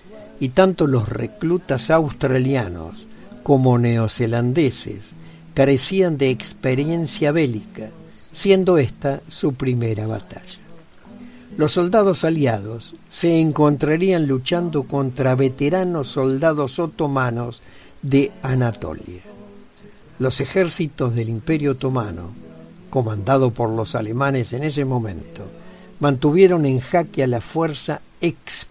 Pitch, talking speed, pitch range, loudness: 140 Hz, 100 wpm, 120-165 Hz, -19 LUFS